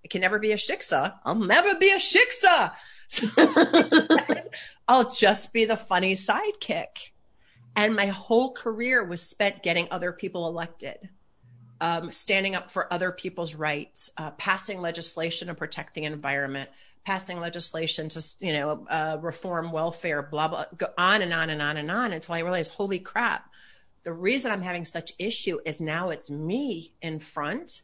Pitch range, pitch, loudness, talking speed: 160-205 Hz, 175 Hz, -25 LUFS, 165 wpm